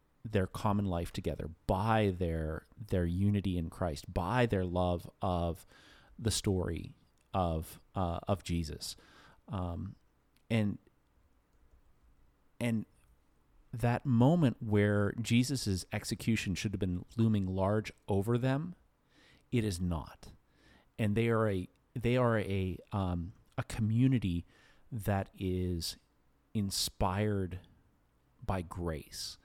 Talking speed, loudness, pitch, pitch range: 110 wpm, -34 LUFS, 100 Hz, 85-110 Hz